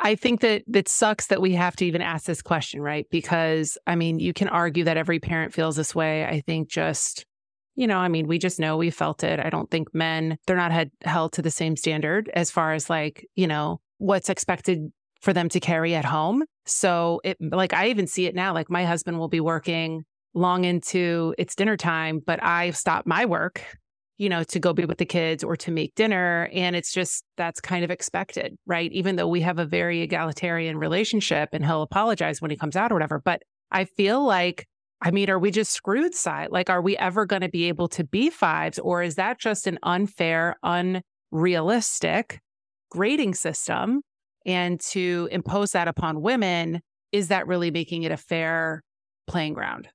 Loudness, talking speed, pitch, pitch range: -24 LUFS, 205 wpm, 175 Hz, 165-190 Hz